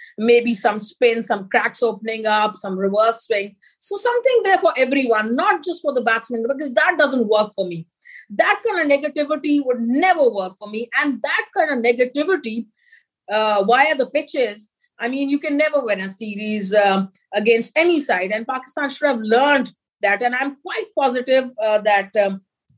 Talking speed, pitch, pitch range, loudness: 180 wpm, 245 Hz, 215-295 Hz, -19 LUFS